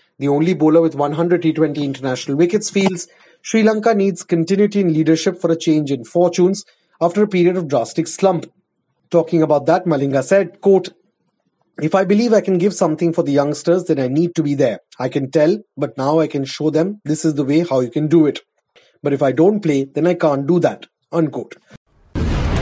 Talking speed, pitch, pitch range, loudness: 205 wpm, 165 Hz, 145-180 Hz, -17 LUFS